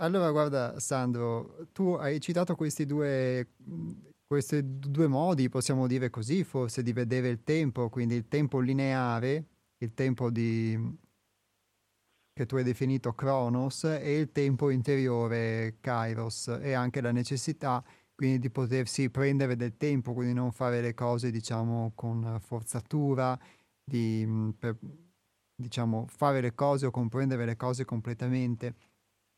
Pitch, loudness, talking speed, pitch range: 125 Hz, -31 LUFS, 135 wpm, 115-140 Hz